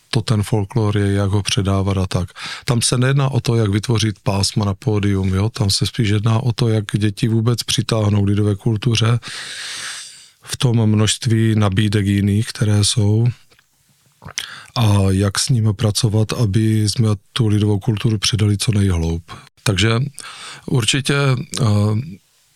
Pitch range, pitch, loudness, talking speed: 105-120 Hz, 110 Hz, -18 LUFS, 145 wpm